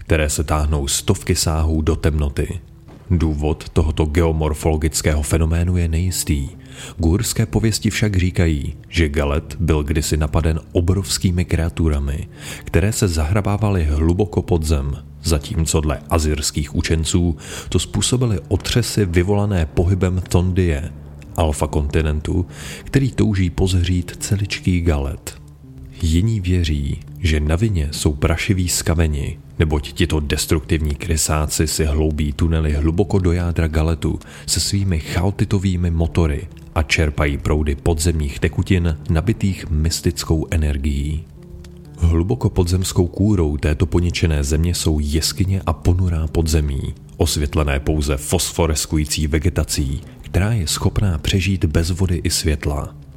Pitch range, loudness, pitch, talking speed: 75-90 Hz, -19 LUFS, 80 Hz, 115 wpm